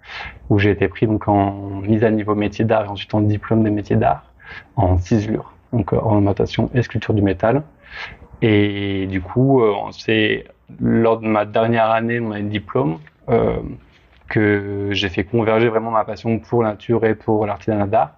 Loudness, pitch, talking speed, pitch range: -19 LUFS, 105 Hz, 170 wpm, 100-115 Hz